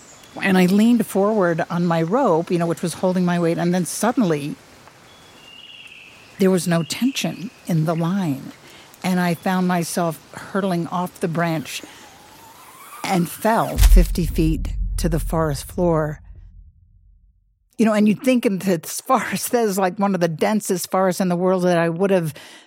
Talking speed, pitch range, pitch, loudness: 165 wpm, 165-195 Hz, 180 Hz, -20 LUFS